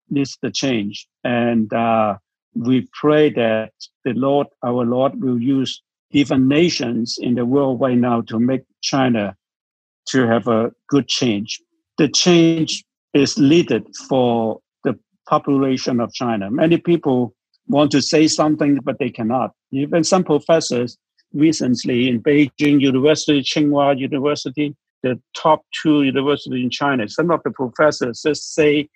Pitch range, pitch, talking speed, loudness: 120-150 Hz, 135 Hz, 140 wpm, -18 LUFS